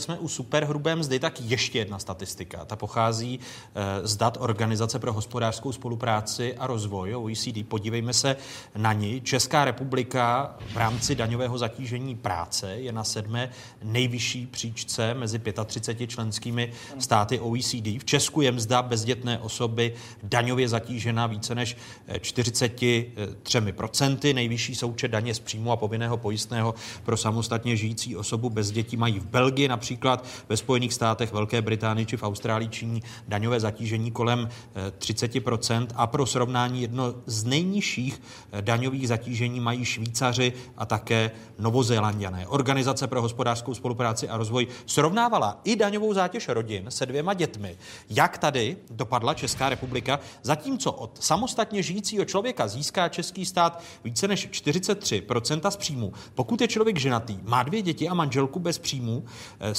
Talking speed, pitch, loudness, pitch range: 140 wpm, 120 Hz, -27 LUFS, 115-130 Hz